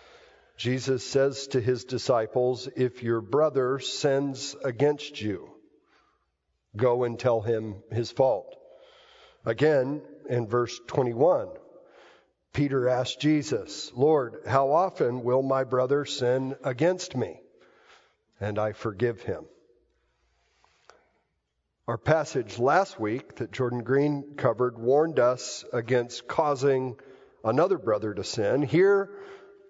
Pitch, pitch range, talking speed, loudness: 130 Hz, 120-145 Hz, 110 wpm, -27 LUFS